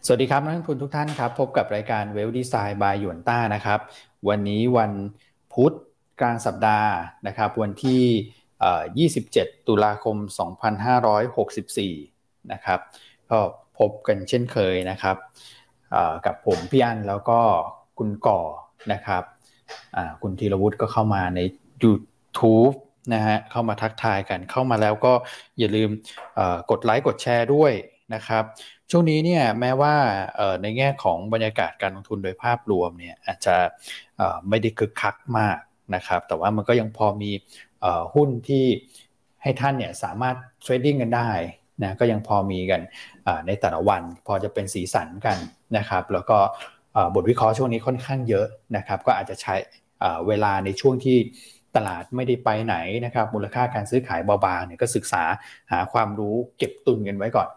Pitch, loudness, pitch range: 110 Hz, -23 LUFS, 105-125 Hz